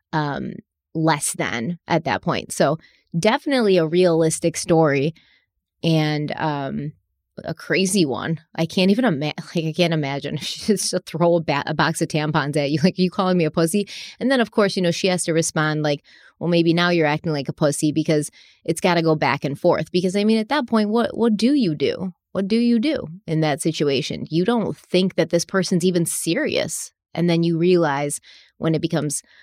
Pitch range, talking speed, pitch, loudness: 155-185 Hz, 210 wpm, 165 Hz, -21 LUFS